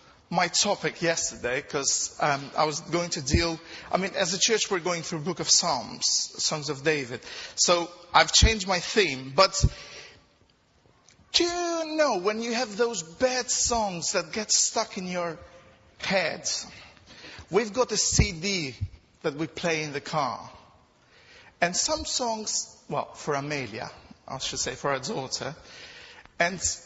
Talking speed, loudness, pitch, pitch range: 155 wpm, -26 LUFS, 190 Hz, 165-230 Hz